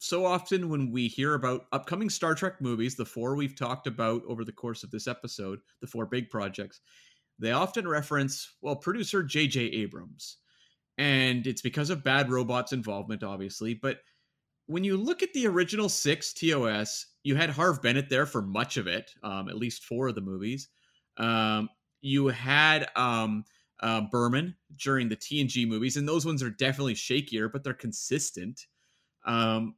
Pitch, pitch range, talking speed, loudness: 130 Hz, 115-150 Hz, 170 wpm, -29 LUFS